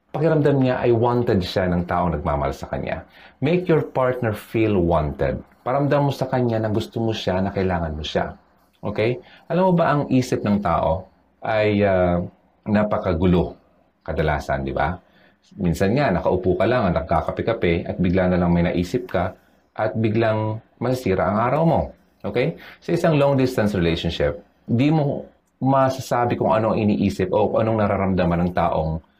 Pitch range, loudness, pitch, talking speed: 90-130 Hz, -21 LUFS, 110 Hz, 160 wpm